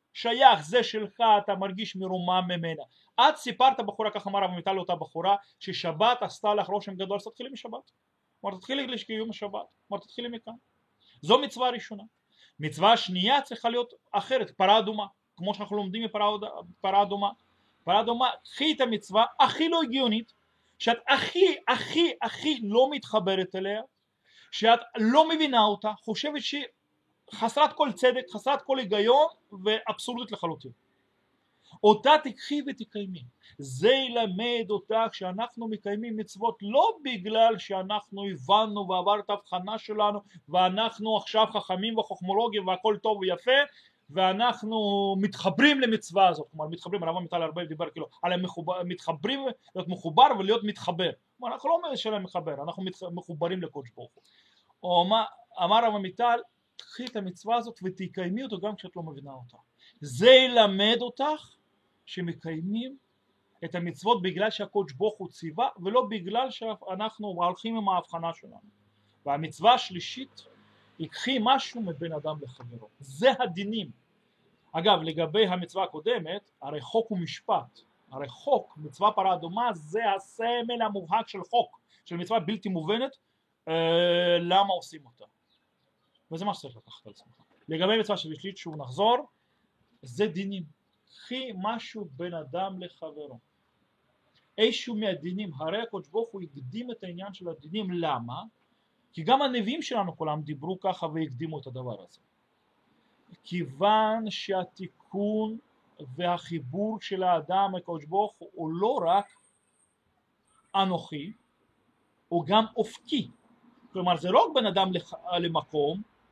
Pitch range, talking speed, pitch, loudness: 175-230 Hz, 130 wpm, 205 Hz, -27 LUFS